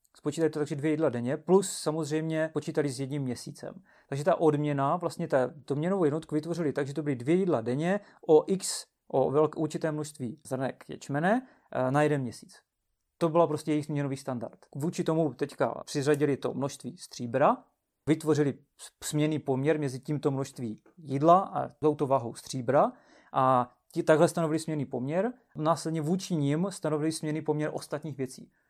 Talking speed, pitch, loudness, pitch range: 165 wpm, 150 Hz, -29 LUFS, 140-160 Hz